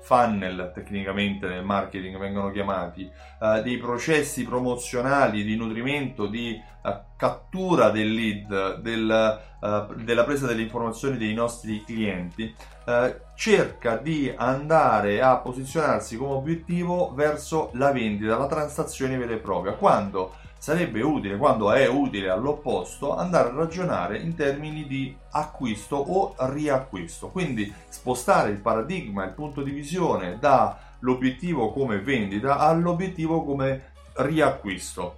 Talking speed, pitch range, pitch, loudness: 120 wpm, 105-145 Hz, 120 Hz, -25 LUFS